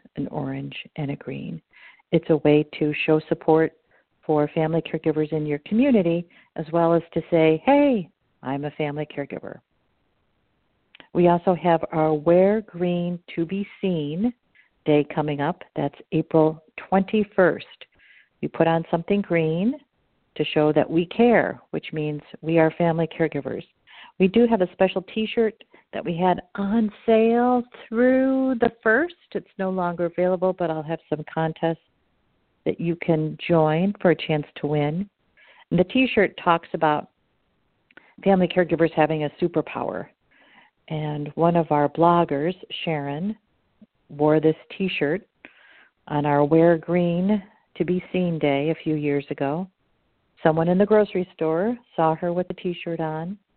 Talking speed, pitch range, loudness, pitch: 150 wpm, 155-190 Hz, -23 LUFS, 170 Hz